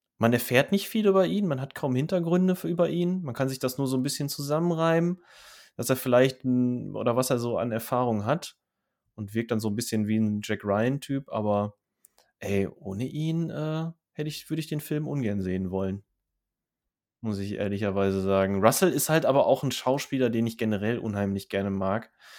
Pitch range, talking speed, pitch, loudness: 105-150 Hz, 200 wpm, 125 Hz, -27 LUFS